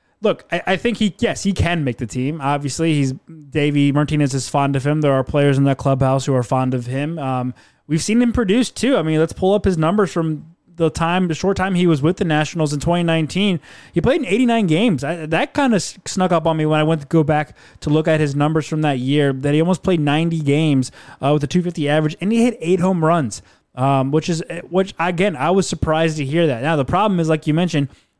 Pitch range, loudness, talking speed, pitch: 145-180 Hz, -18 LUFS, 250 wpm, 160 Hz